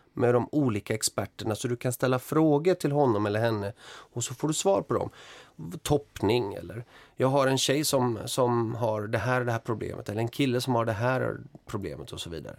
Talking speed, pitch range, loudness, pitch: 220 wpm, 115-140 Hz, -28 LUFS, 125 Hz